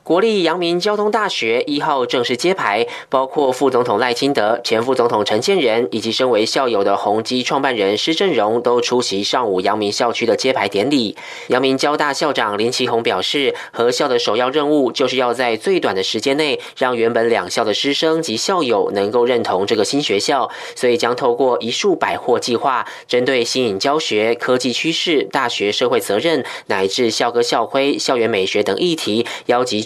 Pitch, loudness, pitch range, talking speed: 125 Hz, -17 LUFS, 115-160 Hz, 295 characters per minute